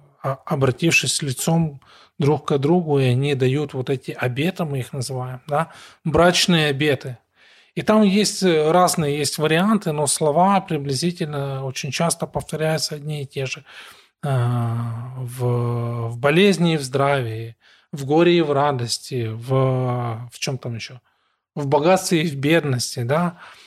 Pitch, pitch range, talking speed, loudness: 145 Hz, 130-165 Hz, 135 wpm, -20 LUFS